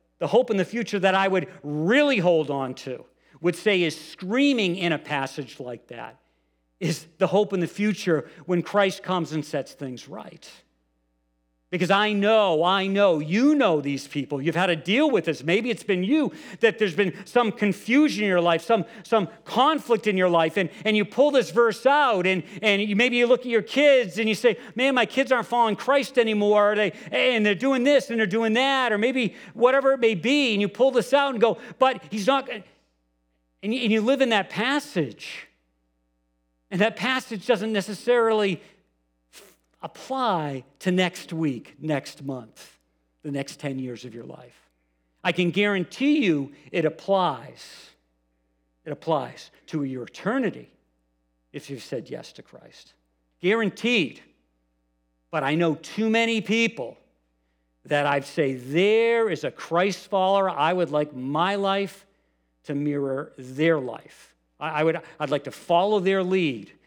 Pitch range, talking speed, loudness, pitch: 140-225 Hz, 170 wpm, -23 LUFS, 185 Hz